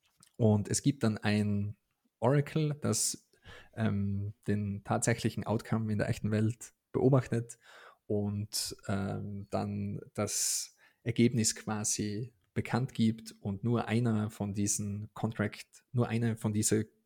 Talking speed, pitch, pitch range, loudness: 120 wpm, 110 Hz, 105-115 Hz, -32 LUFS